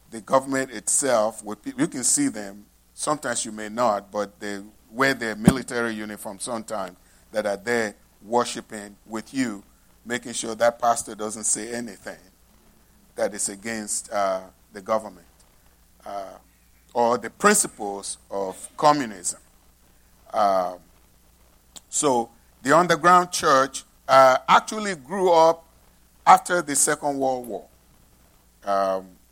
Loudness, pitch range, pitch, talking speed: -23 LUFS, 95-135 Hz, 110 Hz, 120 wpm